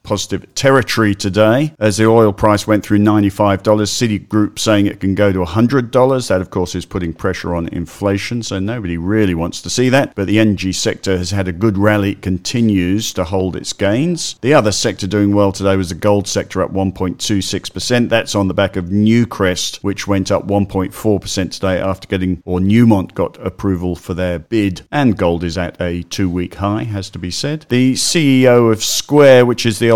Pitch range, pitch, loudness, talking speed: 95-110 Hz, 100 Hz, -15 LUFS, 195 wpm